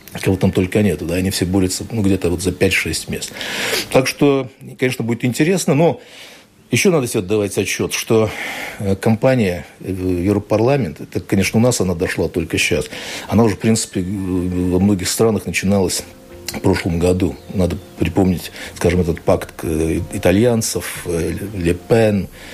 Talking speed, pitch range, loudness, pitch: 145 wpm, 90-110 Hz, -18 LUFS, 95 Hz